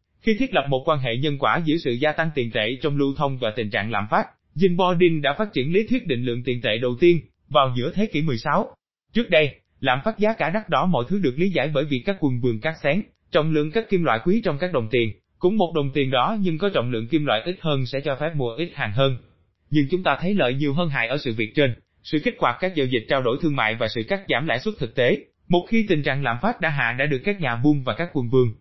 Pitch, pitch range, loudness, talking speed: 145 Hz, 125-175 Hz, -22 LUFS, 285 wpm